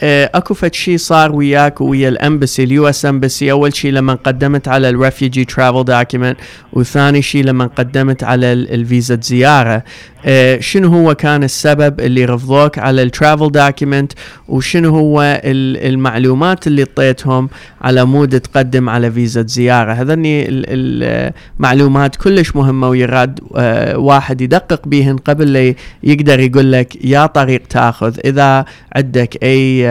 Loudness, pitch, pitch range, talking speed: -11 LUFS, 135 Hz, 125-145 Hz, 125 wpm